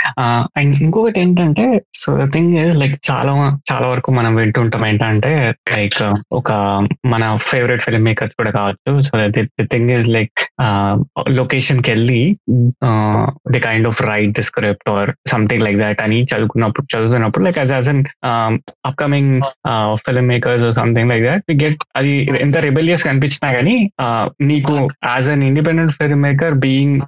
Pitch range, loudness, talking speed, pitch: 115-140 Hz, -14 LUFS, 135 wpm, 125 Hz